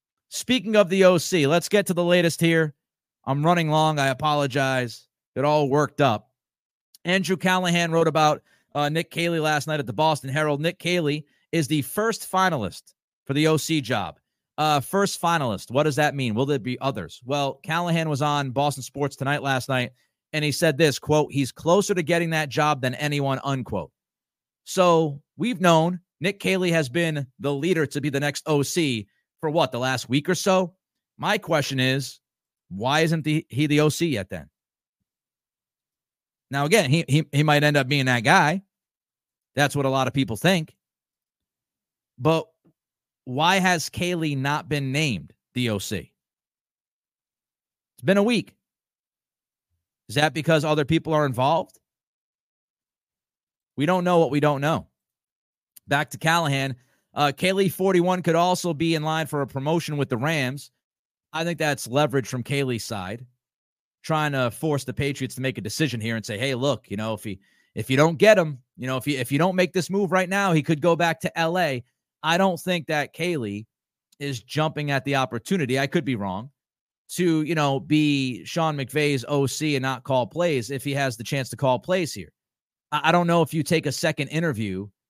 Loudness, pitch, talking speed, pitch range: -23 LUFS, 150 Hz, 185 wpm, 135-165 Hz